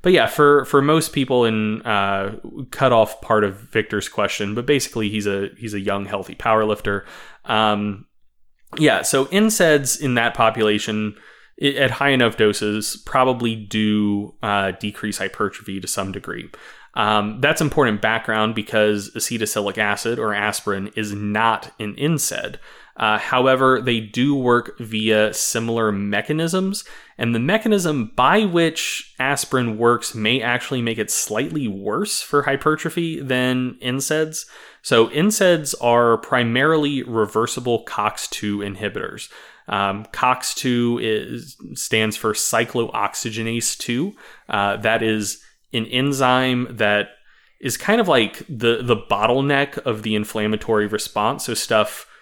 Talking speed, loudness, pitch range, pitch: 135 wpm, -20 LUFS, 105-130 Hz, 115 Hz